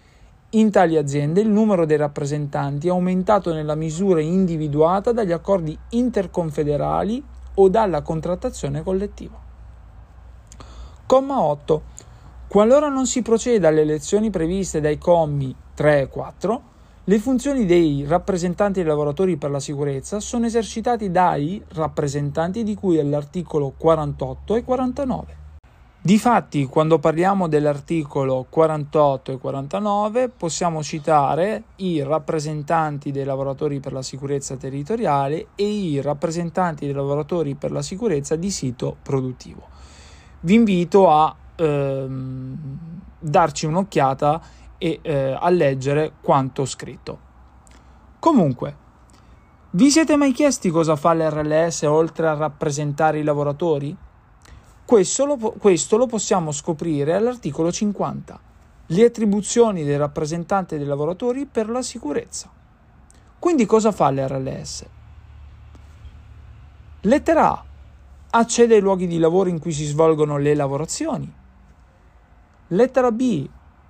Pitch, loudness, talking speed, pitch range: 160 Hz, -20 LUFS, 115 wpm, 145-200 Hz